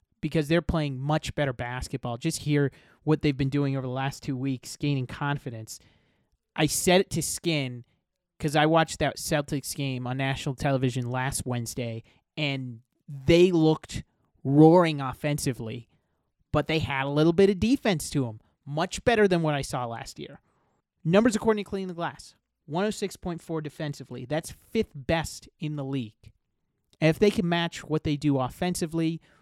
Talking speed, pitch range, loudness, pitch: 165 wpm, 135-165 Hz, -27 LUFS, 150 Hz